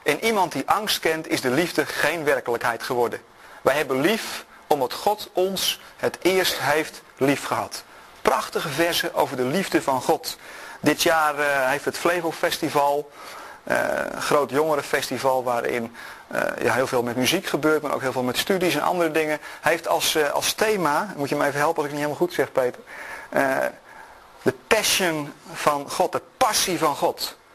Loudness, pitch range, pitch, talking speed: -23 LUFS, 140-175 Hz, 150 Hz, 170 wpm